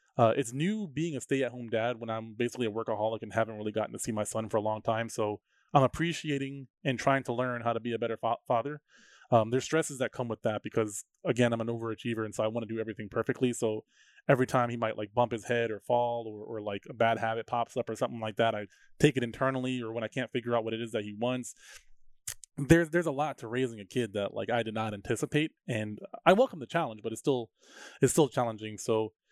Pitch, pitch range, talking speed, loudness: 120 Hz, 110-130 Hz, 250 wpm, -31 LUFS